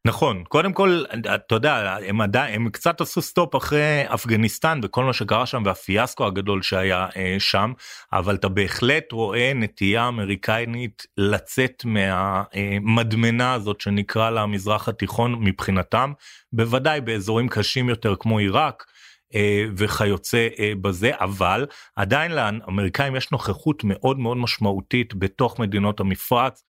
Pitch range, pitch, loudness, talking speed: 100-125 Hz, 110 Hz, -22 LUFS, 120 wpm